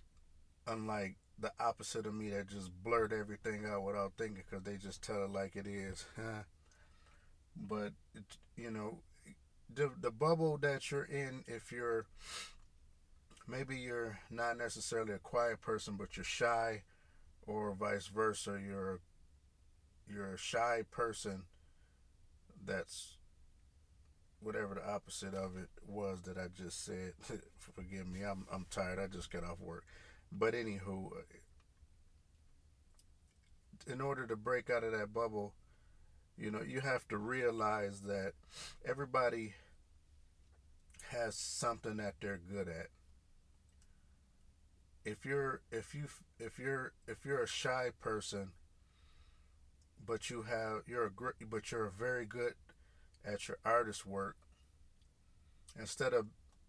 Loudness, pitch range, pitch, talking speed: -41 LUFS, 80-115 Hz, 100 Hz, 130 wpm